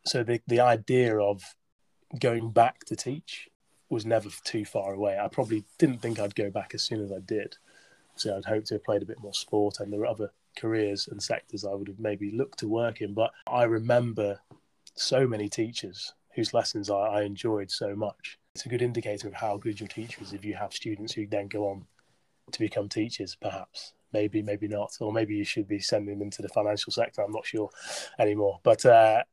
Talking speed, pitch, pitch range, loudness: 215 wpm, 105 Hz, 100-115 Hz, -29 LUFS